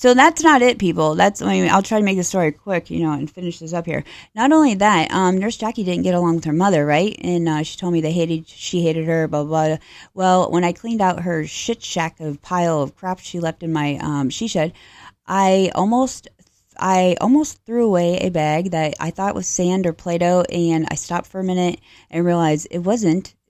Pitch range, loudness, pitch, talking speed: 160-195 Hz, -19 LUFS, 175 Hz, 240 wpm